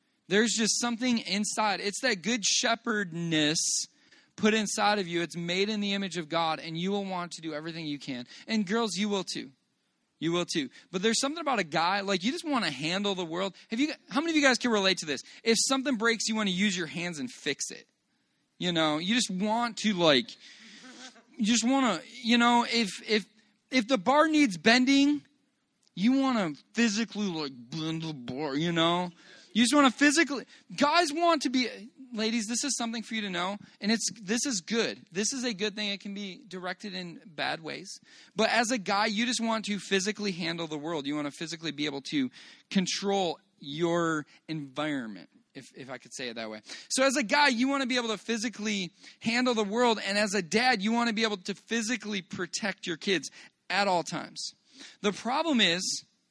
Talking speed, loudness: 215 wpm, -28 LUFS